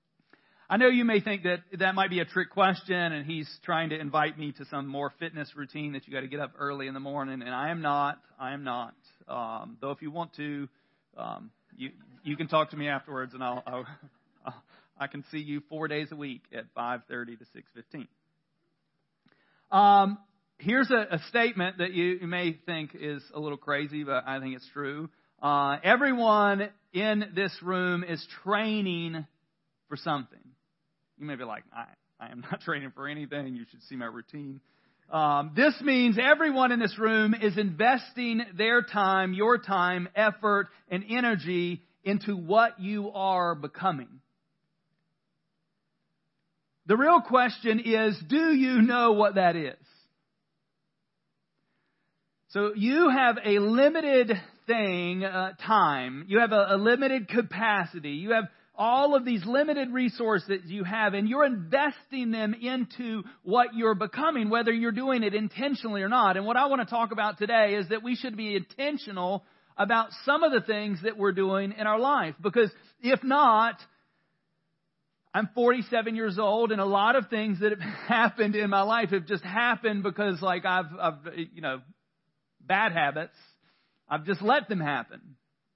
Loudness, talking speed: -27 LUFS, 165 wpm